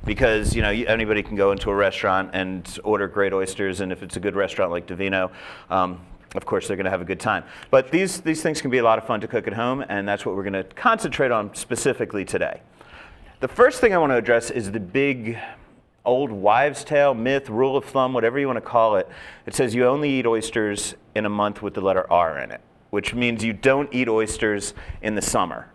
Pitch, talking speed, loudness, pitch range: 110 Hz, 240 wpm, -22 LUFS, 100-130 Hz